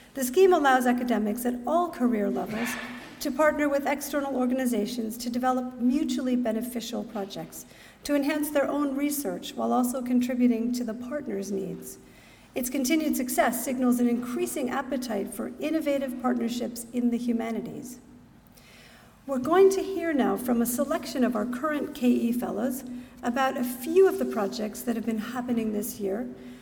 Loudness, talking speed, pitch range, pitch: -27 LUFS, 155 wpm, 235-280 Hz, 250 Hz